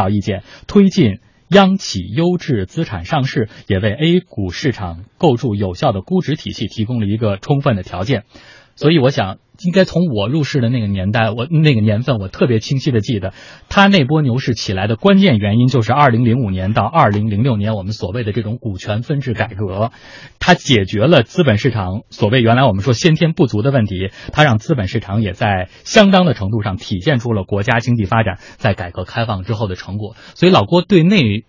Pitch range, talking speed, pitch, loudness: 105-145 Hz, 315 characters per minute, 115 Hz, -15 LUFS